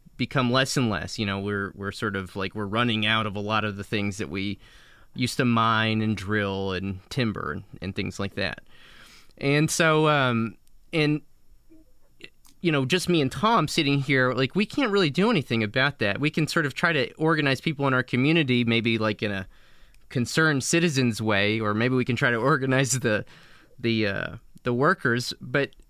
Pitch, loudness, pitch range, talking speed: 120 Hz, -24 LUFS, 105-150 Hz, 195 wpm